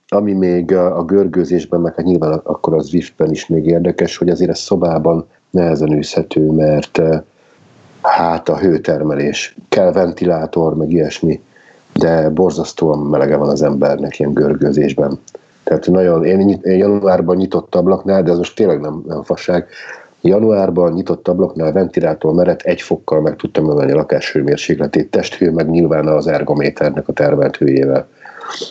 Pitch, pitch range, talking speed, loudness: 85 Hz, 80-90 Hz, 140 wpm, -14 LUFS